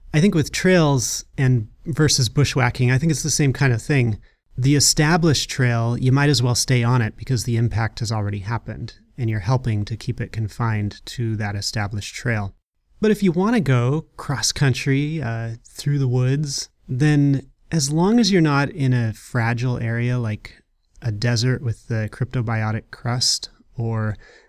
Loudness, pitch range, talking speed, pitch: -20 LUFS, 115-140 Hz, 175 wpm, 125 Hz